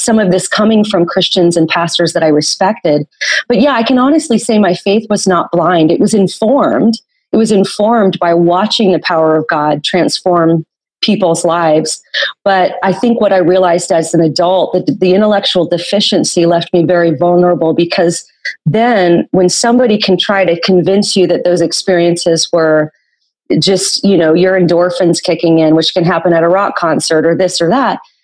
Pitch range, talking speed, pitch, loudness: 170-200 Hz, 180 wpm, 180 Hz, -10 LUFS